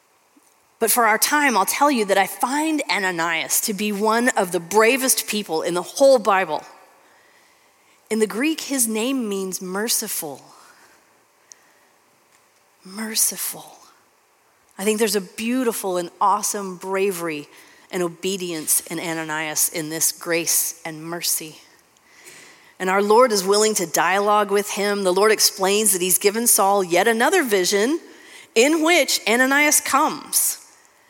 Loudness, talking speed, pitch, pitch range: -19 LUFS, 135 wpm, 205 Hz, 180-235 Hz